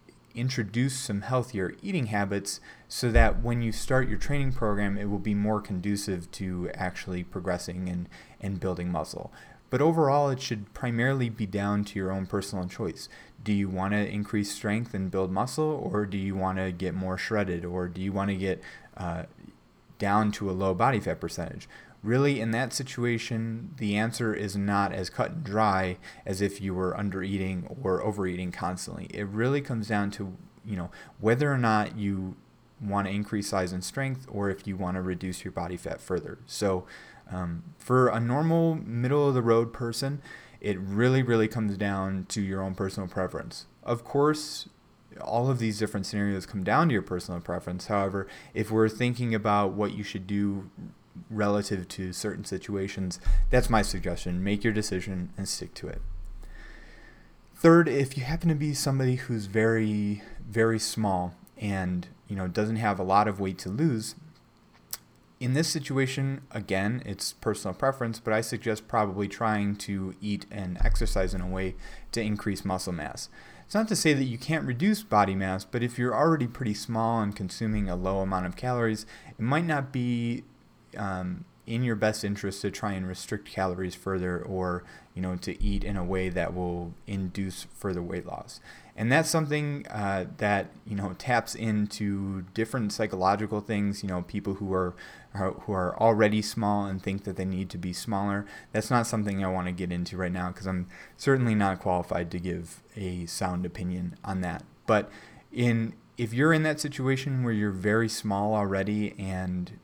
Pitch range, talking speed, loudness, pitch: 95-115 Hz, 180 wpm, -29 LUFS, 100 Hz